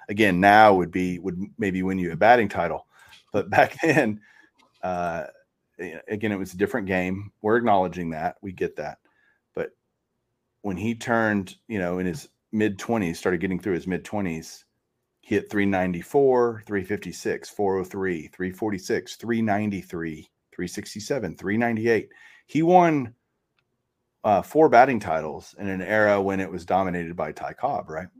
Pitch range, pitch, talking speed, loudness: 90-110 Hz, 100 Hz, 145 wpm, -24 LUFS